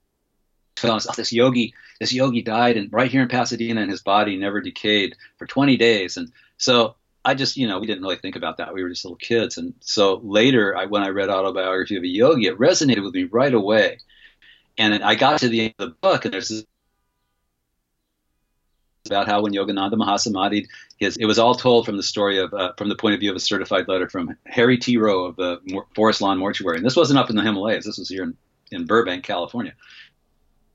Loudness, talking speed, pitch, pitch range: -20 LUFS, 220 wpm, 105 Hz, 95-120 Hz